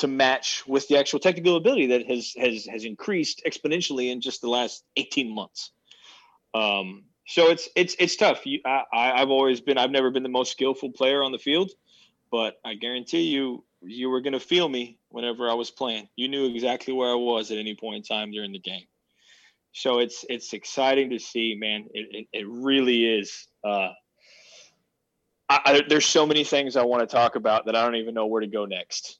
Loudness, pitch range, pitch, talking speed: -24 LUFS, 115-135 Hz, 125 Hz, 210 wpm